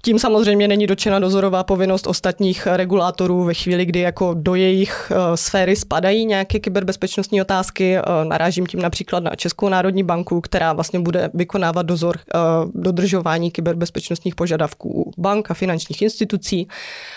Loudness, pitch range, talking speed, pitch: -18 LUFS, 175-195 Hz, 135 wpm, 185 Hz